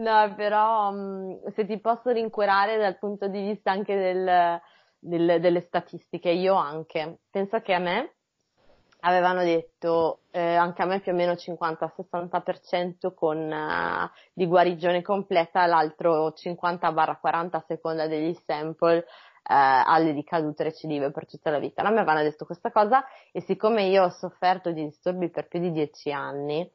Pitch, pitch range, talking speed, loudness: 175 Hz, 165-195 Hz, 155 wpm, -25 LUFS